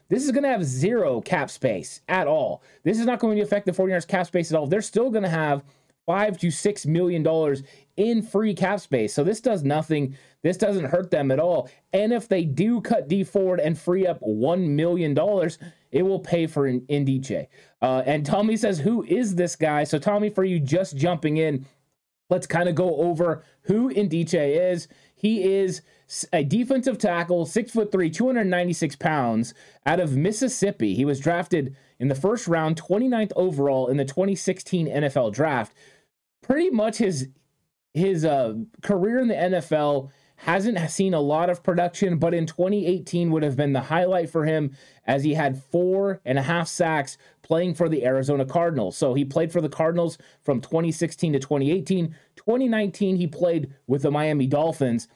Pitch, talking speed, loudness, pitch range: 170 Hz, 185 wpm, -23 LUFS, 145-195 Hz